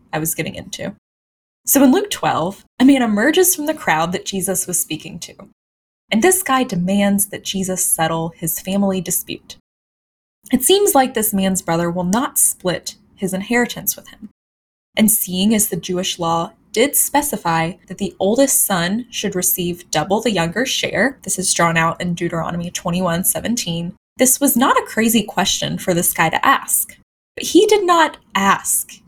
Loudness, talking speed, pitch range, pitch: -17 LUFS, 175 wpm, 175-250 Hz, 195 Hz